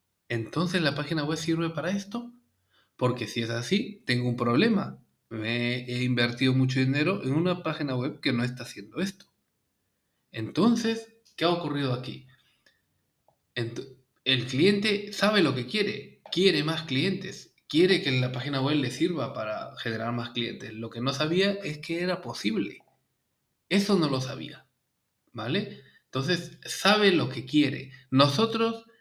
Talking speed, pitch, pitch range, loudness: 150 wpm, 145 Hz, 125-185 Hz, -27 LUFS